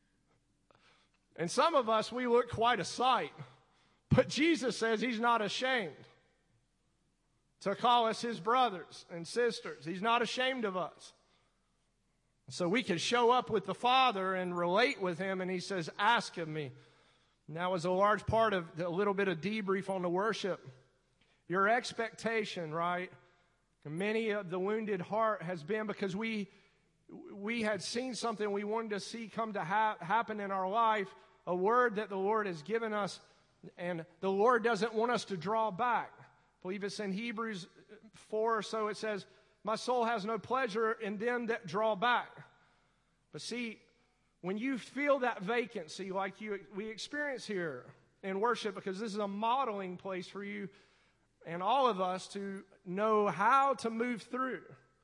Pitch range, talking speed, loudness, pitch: 185-230 Hz, 170 wpm, -34 LUFS, 210 Hz